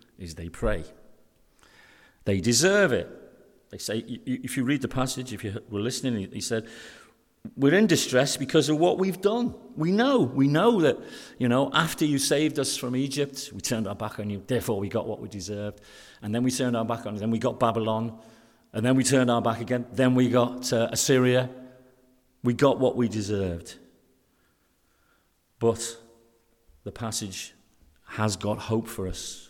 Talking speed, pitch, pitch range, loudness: 180 wpm, 120 Hz, 110-130 Hz, -26 LUFS